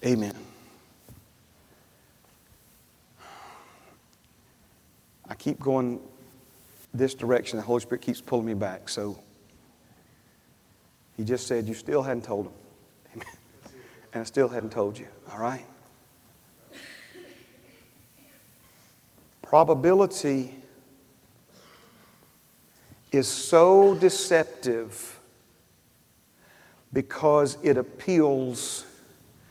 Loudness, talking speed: -25 LUFS, 75 wpm